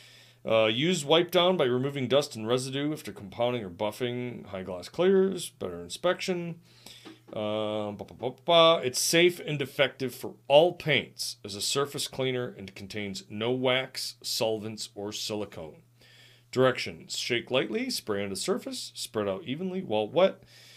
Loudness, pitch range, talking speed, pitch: -28 LUFS, 105-145 Hz, 140 wpm, 125 Hz